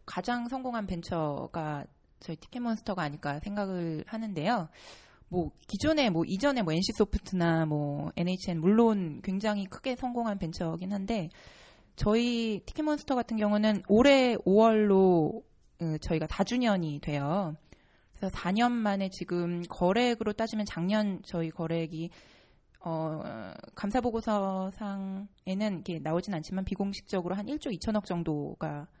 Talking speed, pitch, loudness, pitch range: 290 characters per minute, 195 Hz, -30 LUFS, 165-220 Hz